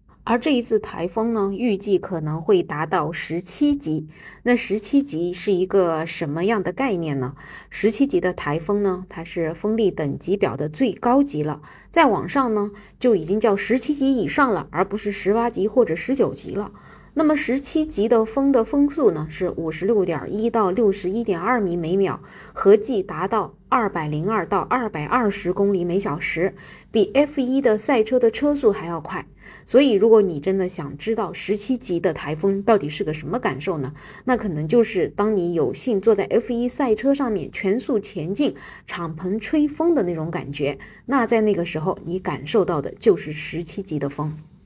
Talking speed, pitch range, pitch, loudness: 275 characters per minute, 170-235 Hz, 200 Hz, -22 LUFS